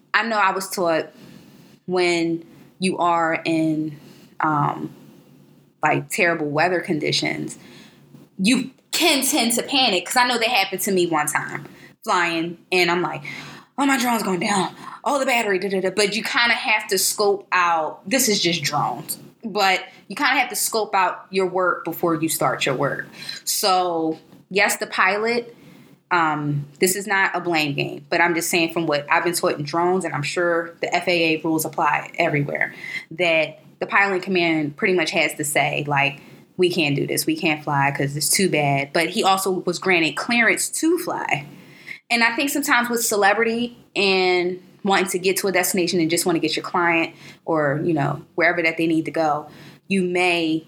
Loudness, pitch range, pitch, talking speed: -20 LUFS, 165-200 Hz, 180 Hz, 190 wpm